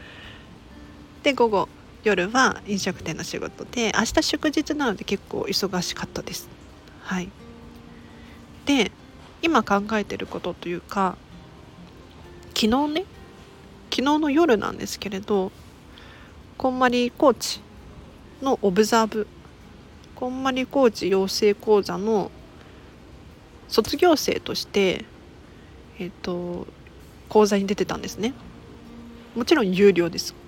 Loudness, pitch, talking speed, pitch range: -23 LUFS, 210 Hz, 210 characters per minute, 185-255 Hz